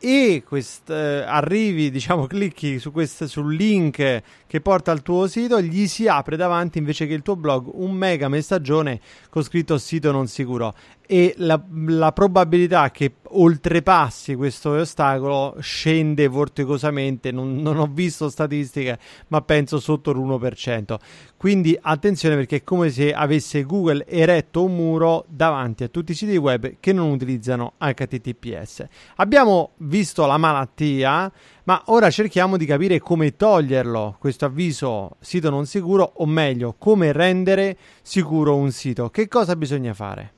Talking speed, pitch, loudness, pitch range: 145 wpm, 155 Hz, -20 LUFS, 140-175 Hz